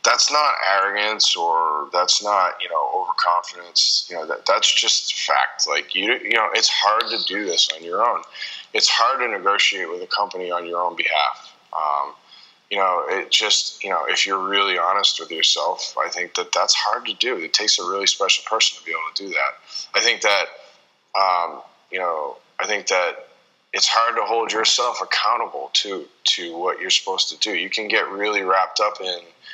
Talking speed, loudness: 200 wpm, -19 LUFS